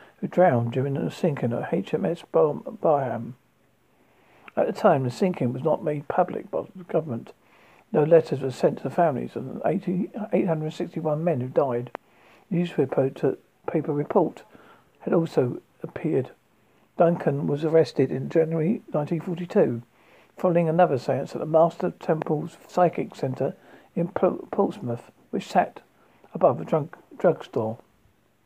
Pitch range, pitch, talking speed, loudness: 140-180 Hz, 160 Hz, 130 wpm, -25 LUFS